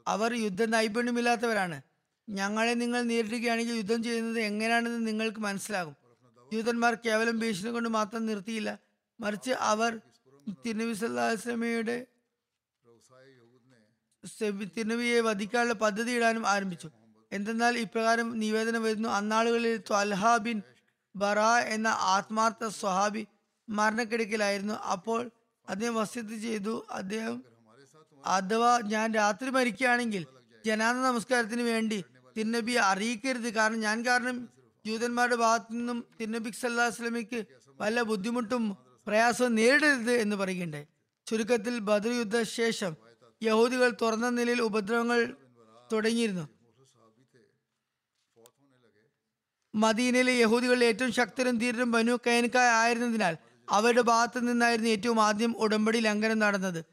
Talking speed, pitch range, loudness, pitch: 90 wpm, 200-235 Hz, -28 LUFS, 225 Hz